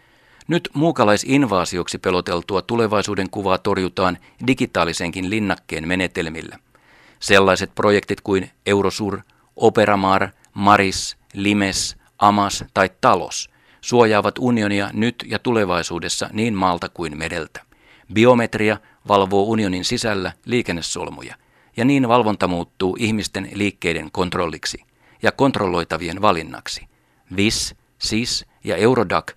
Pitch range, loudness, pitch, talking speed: 95-110 Hz, -19 LUFS, 100 Hz, 95 wpm